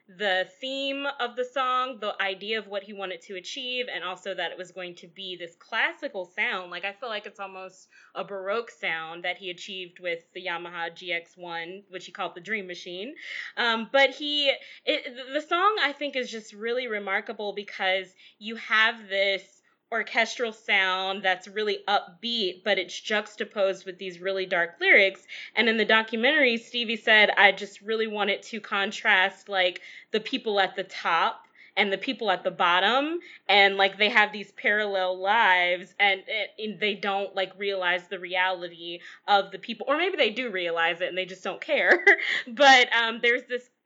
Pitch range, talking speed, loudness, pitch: 185-230 Hz, 180 wpm, -25 LUFS, 200 Hz